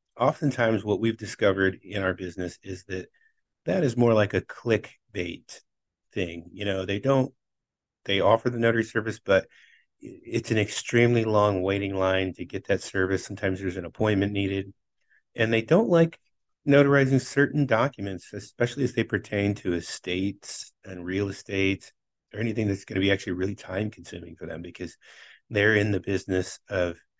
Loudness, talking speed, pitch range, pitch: -26 LUFS, 165 wpm, 95-115 Hz, 100 Hz